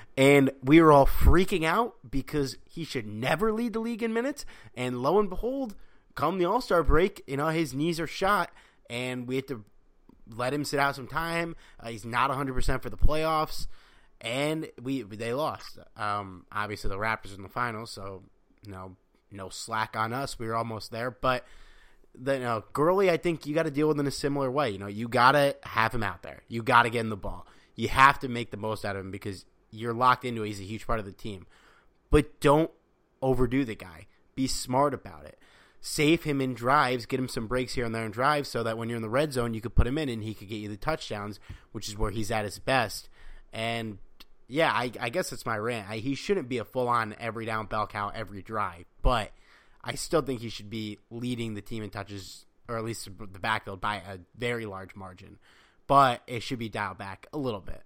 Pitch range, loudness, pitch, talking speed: 105-140 Hz, -28 LUFS, 120 Hz, 230 wpm